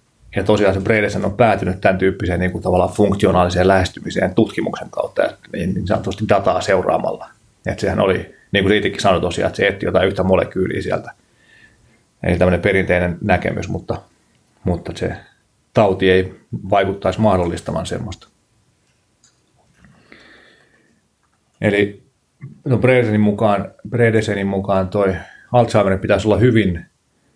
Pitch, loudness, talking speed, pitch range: 100 Hz, -17 LUFS, 125 wpm, 90-110 Hz